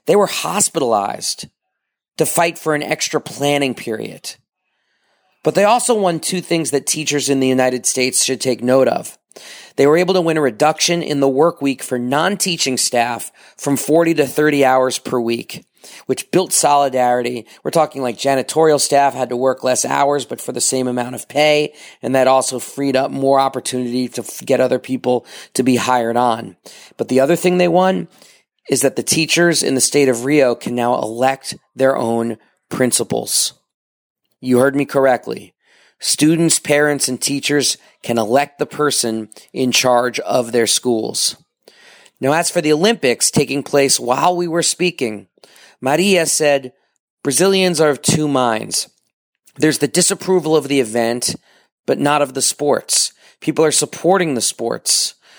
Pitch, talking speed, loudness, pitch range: 135 Hz, 165 wpm, -16 LUFS, 125-155 Hz